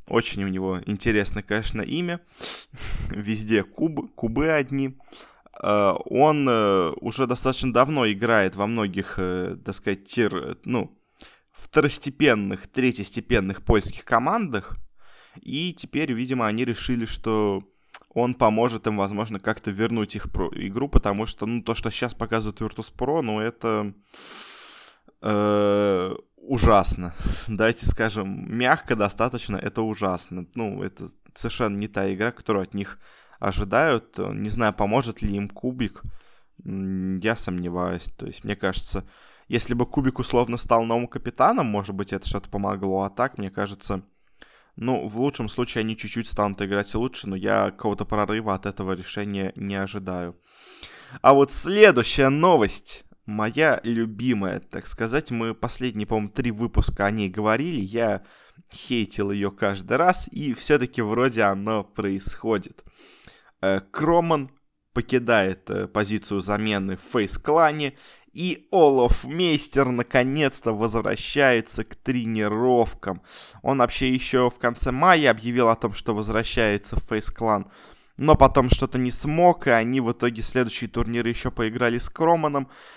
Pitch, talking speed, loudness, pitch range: 110 Hz, 130 wpm, -24 LUFS, 100-125 Hz